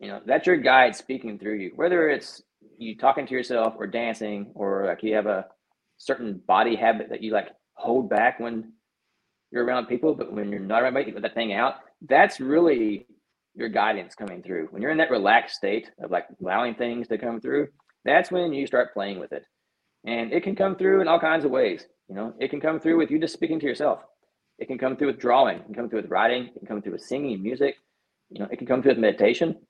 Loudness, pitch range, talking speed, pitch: -24 LUFS, 110-155 Hz, 240 wpm, 125 Hz